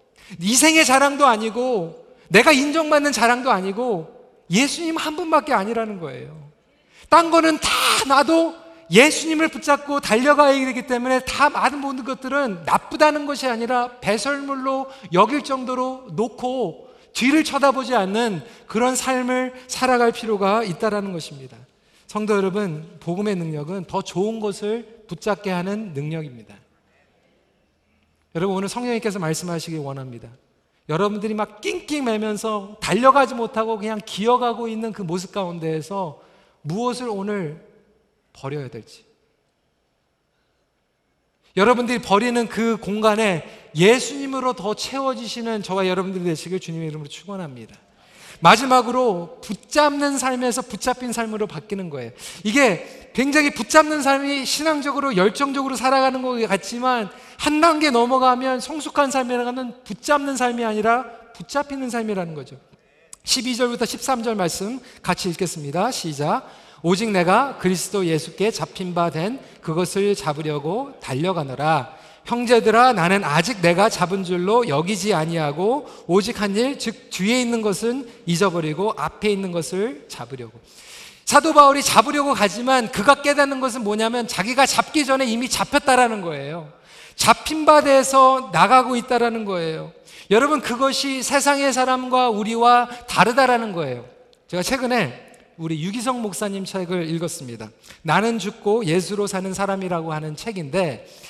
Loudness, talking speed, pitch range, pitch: -20 LUFS, 315 characters per minute, 185-255 Hz, 225 Hz